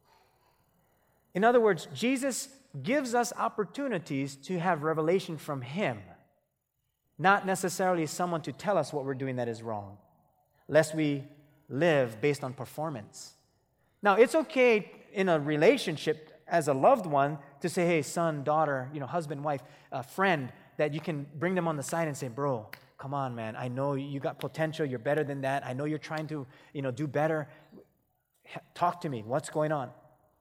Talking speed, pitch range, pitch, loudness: 175 wpm, 140-175 Hz, 155 Hz, -30 LUFS